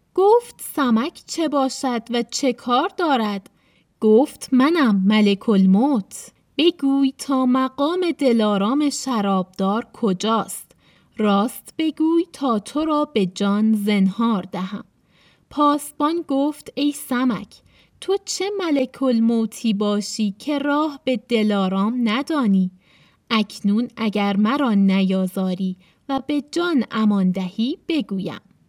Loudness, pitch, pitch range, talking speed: -20 LUFS, 235 Hz, 205-285 Hz, 105 wpm